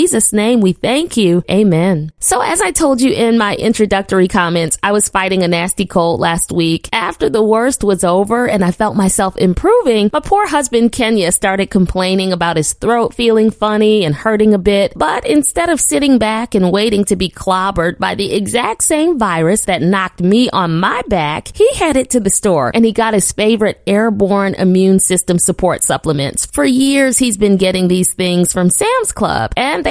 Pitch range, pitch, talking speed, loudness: 185-225 Hz, 200 Hz, 195 wpm, -12 LUFS